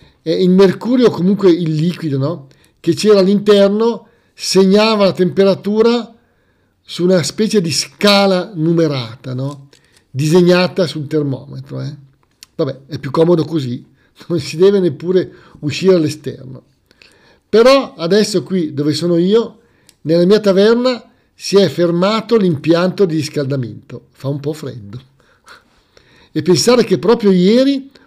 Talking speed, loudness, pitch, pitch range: 125 wpm, -13 LUFS, 175 Hz, 145-200 Hz